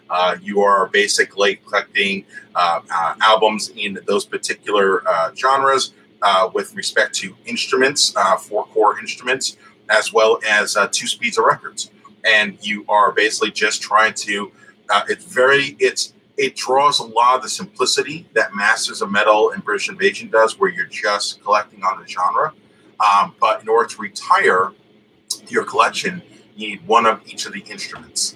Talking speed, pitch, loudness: 165 wpm, 235 Hz, -17 LUFS